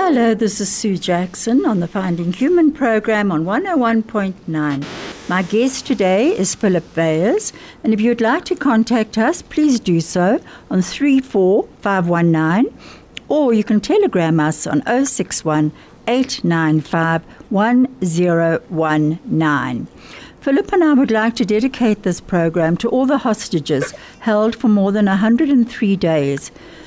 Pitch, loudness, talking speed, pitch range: 210 Hz, -16 LUFS, 130 wpm, 170-245 Hz